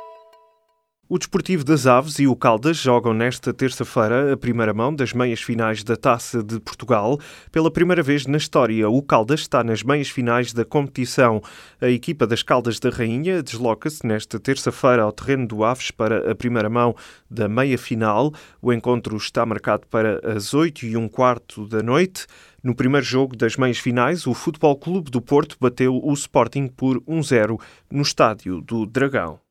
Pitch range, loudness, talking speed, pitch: 115-140 Hz, -20 LUFS, 175 wpm, 125 Hz